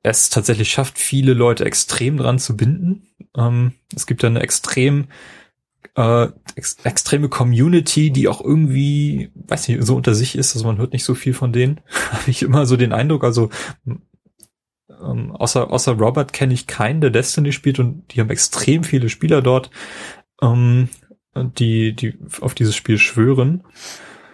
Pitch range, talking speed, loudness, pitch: 120-145 Hz, 170 wpm, -17 LUFS, 130 Hz